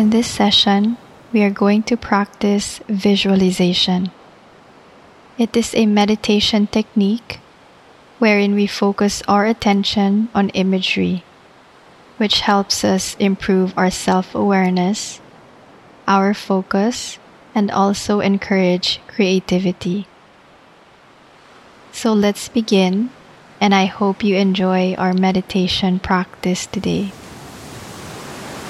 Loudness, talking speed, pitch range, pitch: -17 LUFS, 95 wpm, 190-210 Hz, 200 Hz